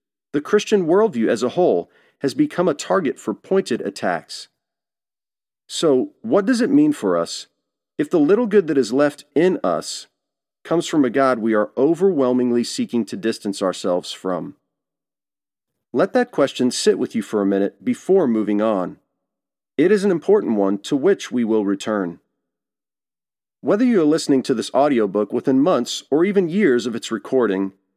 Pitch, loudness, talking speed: 135 Hz, -19 LUFS, 165 wpm